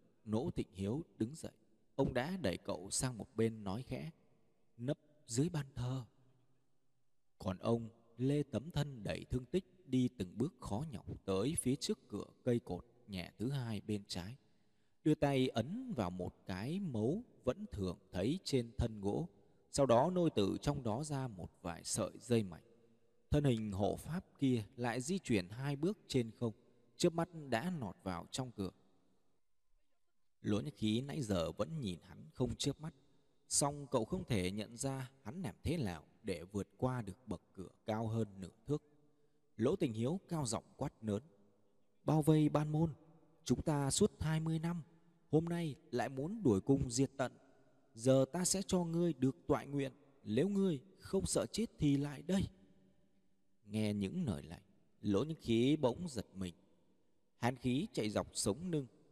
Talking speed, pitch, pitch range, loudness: 175 wpm, 125 Hz, 105-150 Hz, -39 LUFS